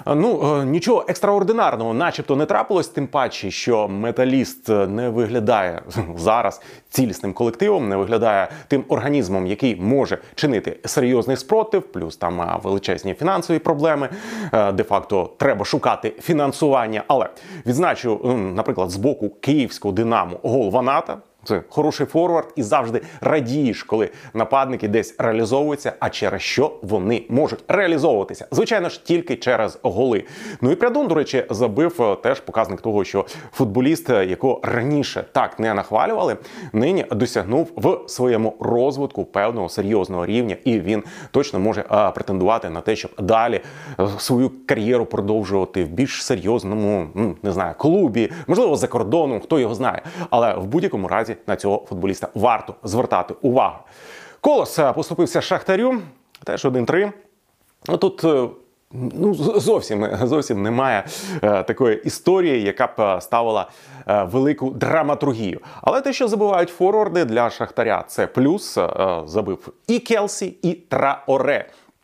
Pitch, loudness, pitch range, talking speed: 130 Hz, -20 LUFS, 110-155 Hz, 130 wpm